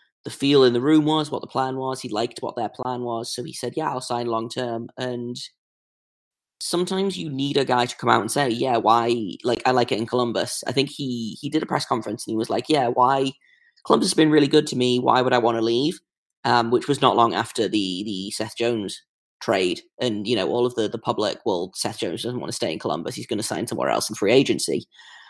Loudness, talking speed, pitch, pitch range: -23 LUFS, 250 wpm, 125 Hz, 120-145 Hz